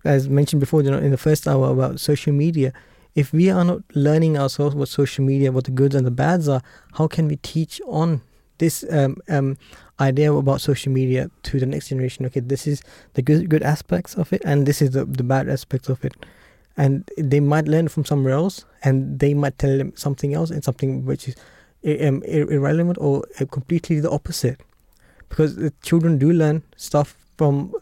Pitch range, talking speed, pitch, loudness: 135-155 Hz, 200 wpm, 145 Hz, -20 LUFS